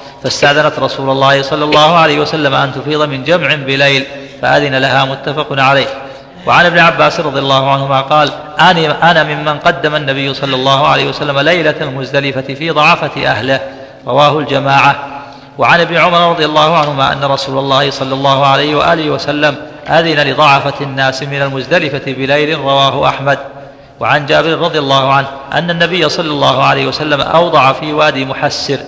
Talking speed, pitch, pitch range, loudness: 160 wpm, 140 Hz, 135-150 Hz, -10 LUFS